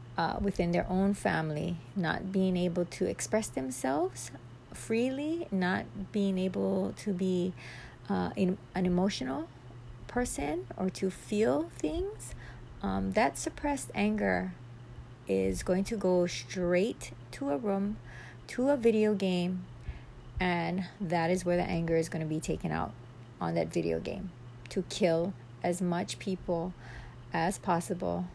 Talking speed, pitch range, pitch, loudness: 140 wpm, 120-190 Hz, 175 Hz, -32 LUFS